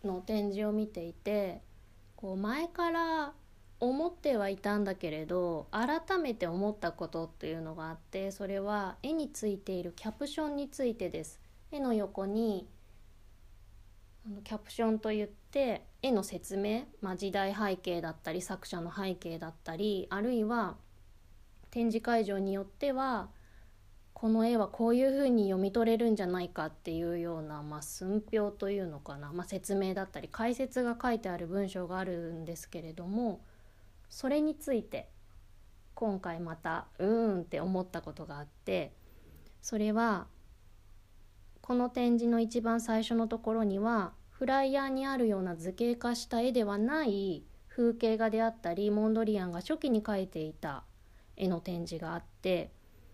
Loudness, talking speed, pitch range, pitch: -34 LUFS, 315 characters per minute, 165-230 Hz, 195 Hz